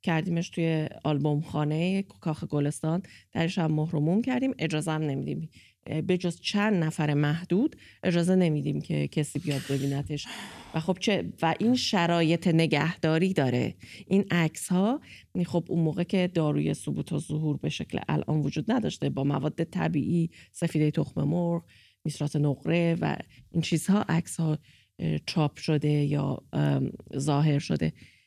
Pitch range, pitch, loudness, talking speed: 145-175 Hz, 160 Hz, -28 LUFS, 140 wpm